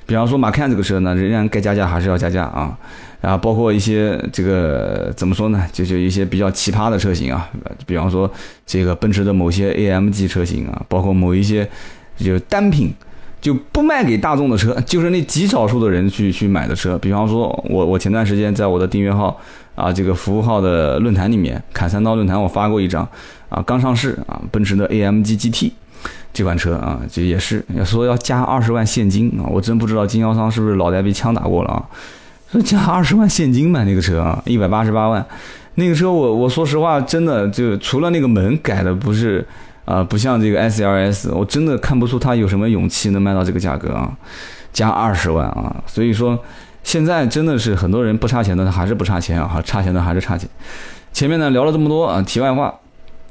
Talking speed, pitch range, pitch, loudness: 325 characters per minute, 95-120 Hz, 105 Hz, -17 LUFS